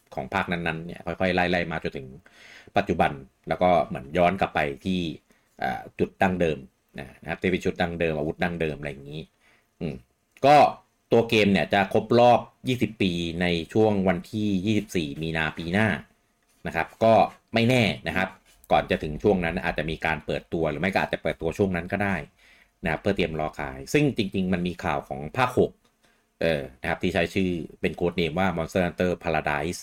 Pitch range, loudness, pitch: 80-95 Hz, -25 LUFS, 90 Hz